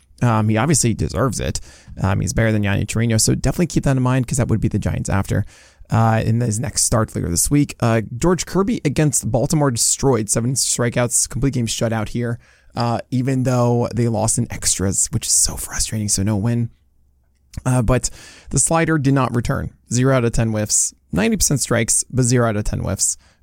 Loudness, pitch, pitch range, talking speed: -18 LUFS, 120 Hz, 110-130 Hz, 200 wpm